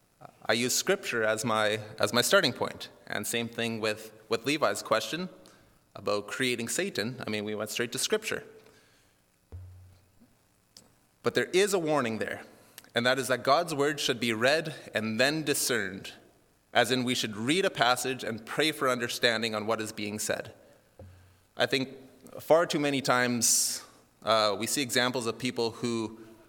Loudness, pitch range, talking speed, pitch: -28 LUFS, 110-130 Hz, 165 wpm, 120 Hz